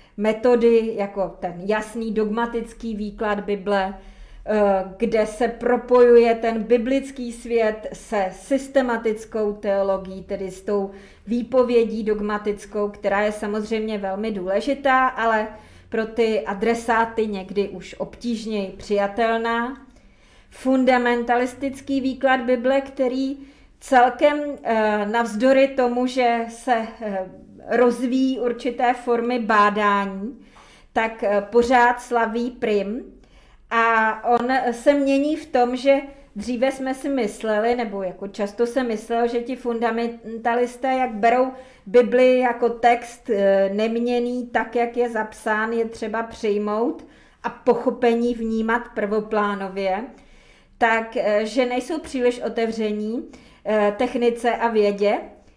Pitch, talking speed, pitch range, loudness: 230 Hz, 100 wpm, 215-245 Hz, -21 LUFS